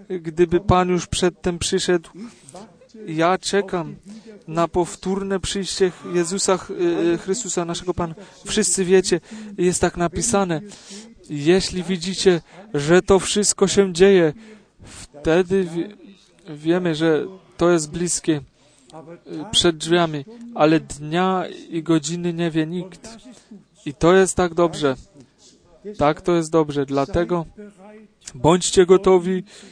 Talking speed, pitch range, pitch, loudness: 105 wpm, 165-195 Hz, 180 Hz, -20 LUFS